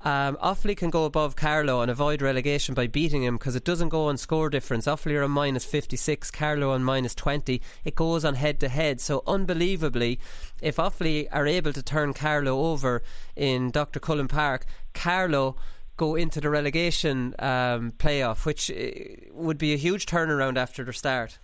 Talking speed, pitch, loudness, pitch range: 180 wpm, 145 Hz, -26 LUFS, 130-160 Hz